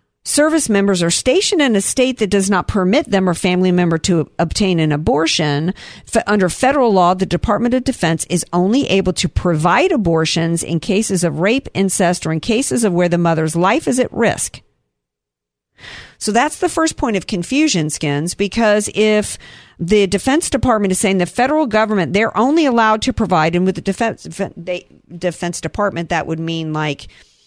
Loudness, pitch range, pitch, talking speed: -16 LUFS, 165-220 Hz, 190 Hz, 175 wpm